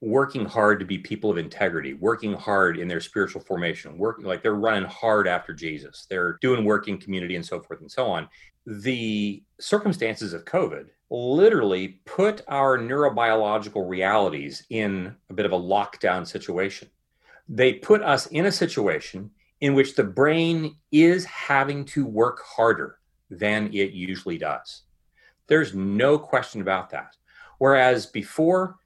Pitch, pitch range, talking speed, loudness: 110 Hz, 100-140 Hz, 150 wpm, -23 LUFS